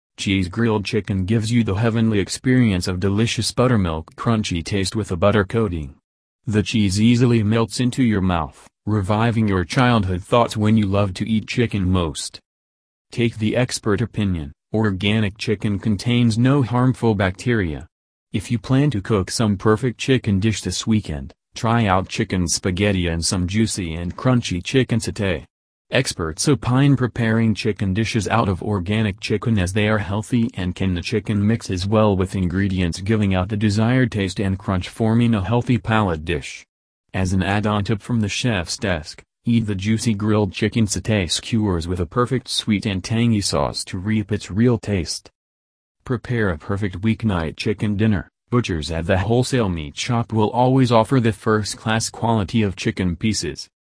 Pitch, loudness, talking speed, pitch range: 105 Hz, -20 LUFS, 165 wpm, 95-115 Hz